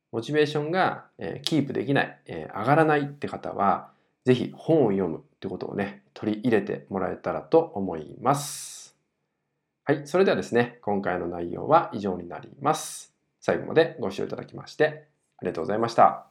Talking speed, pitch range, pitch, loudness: 365 characters per minute, 100-150 Hz, 140 Hz, -26 LUFS